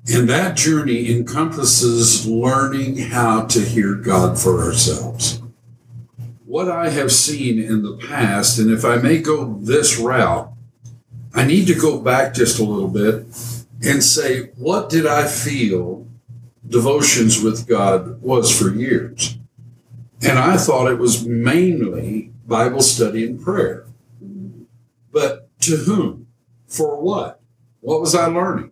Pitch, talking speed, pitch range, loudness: 120 Hz, 135 wpm, 115-135 Hz, -16 LUFS